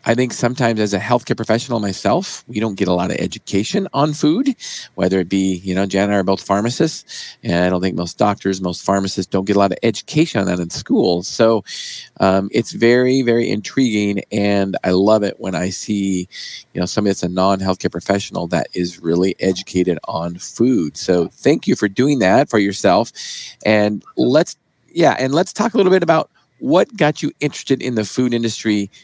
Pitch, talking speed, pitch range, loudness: 100 Hz, 205 wpm, 95-120 Hz, -17 LUFS